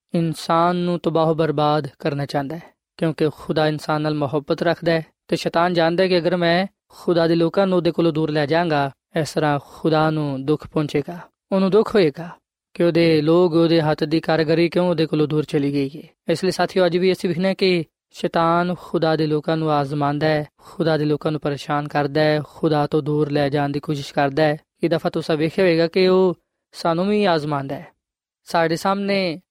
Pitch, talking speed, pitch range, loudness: 165 Hz, 195 wpm, 150-175 Hz, -20 LUFS